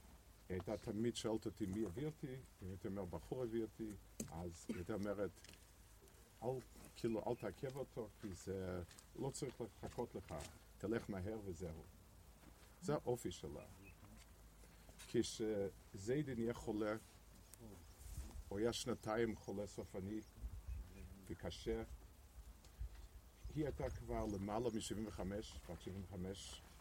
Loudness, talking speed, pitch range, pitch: -47 LUFS, 115 wpm, 85-110 Hz, 100 Hz